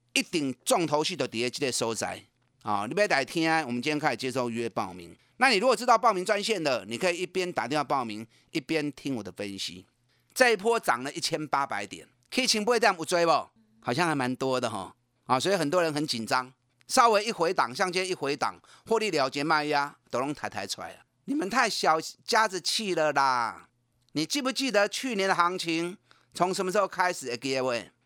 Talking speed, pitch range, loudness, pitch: 325 characters per minute, 125-185 Hz, -27 LUFS, 155 Hz